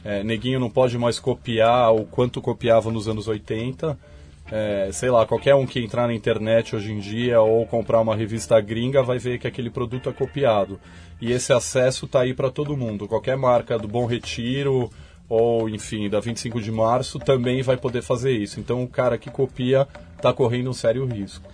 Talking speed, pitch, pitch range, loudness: 195 wpm, 120 Hz, 110-130 Hz, -22 LUFS